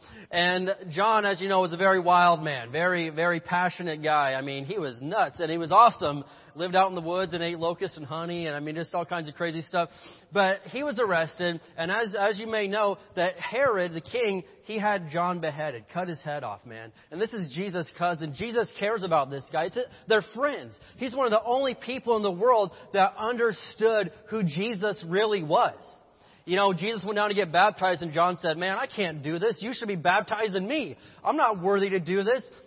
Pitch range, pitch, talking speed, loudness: 170-215 Hz, 185 Hz, 220 wpm, -27 LUFS